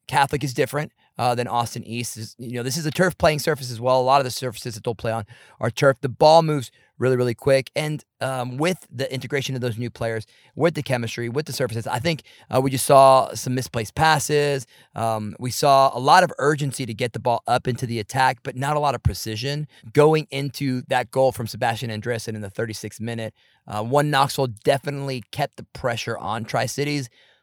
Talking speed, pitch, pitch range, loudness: 220 wpm, 130 Hz, 115-140 Hz, -22 LUFS